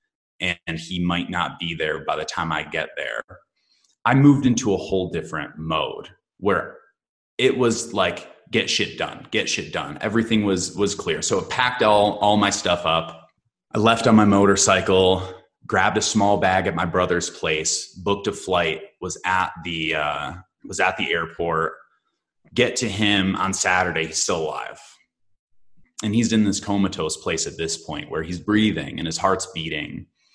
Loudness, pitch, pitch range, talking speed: -21 LUFS, 95 Hz, 85-105 Hz, 175 wpm